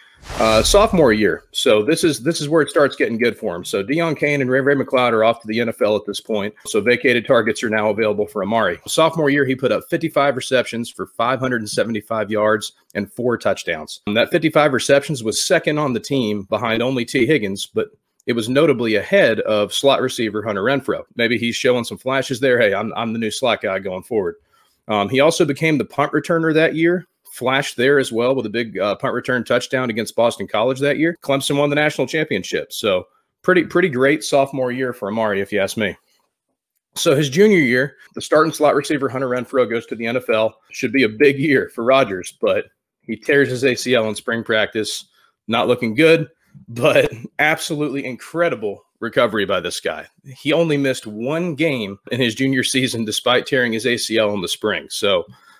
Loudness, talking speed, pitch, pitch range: -18 LUFS, 200 wpm, 130 Hz, 115-150 Hz